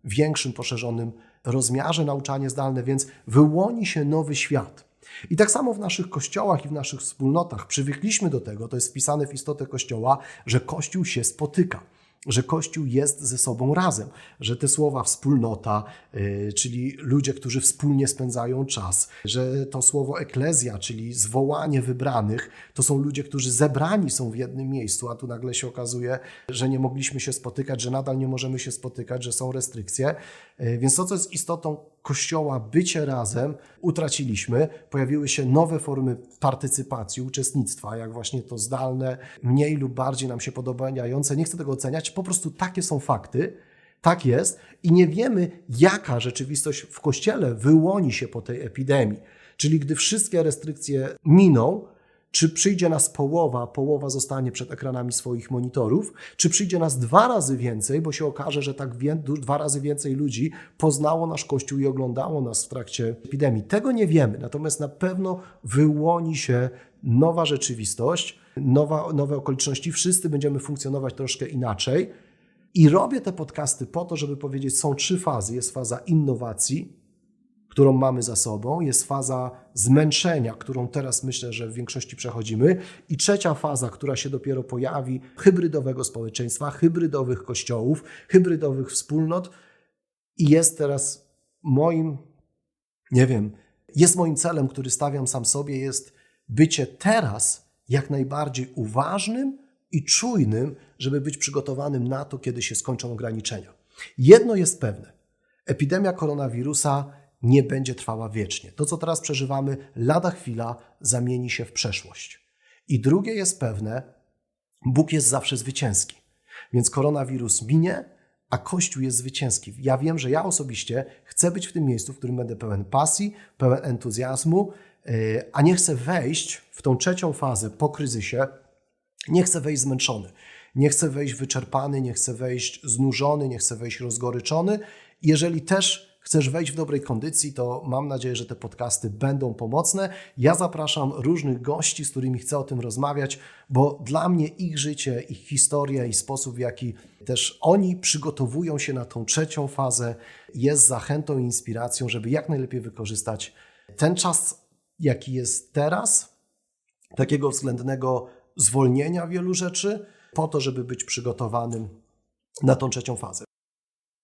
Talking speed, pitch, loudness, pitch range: 150 wpm, 135 Hz, -23 LUFS, 125-155 Hz